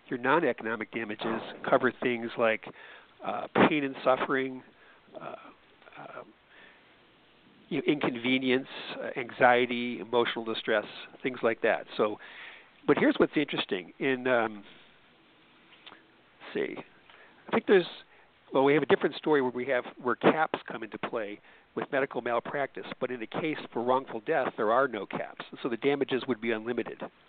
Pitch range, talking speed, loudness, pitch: 115-130 Hz, 145 wpm, -29 LUFS, 125 Hz